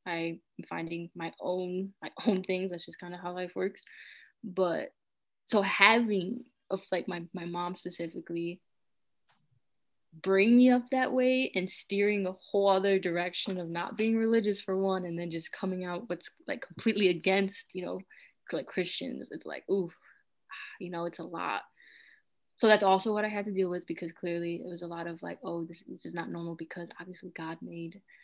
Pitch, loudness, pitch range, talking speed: 185 Hz, -31 LUFS, 170-205 Hz, 185 wpm